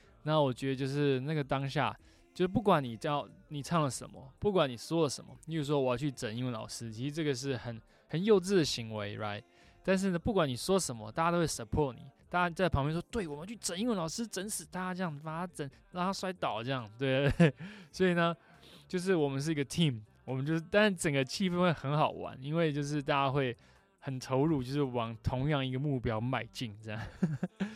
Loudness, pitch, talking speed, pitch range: -33 LUFS, 145 Hz, 350 characters per minute, 130-175 Hz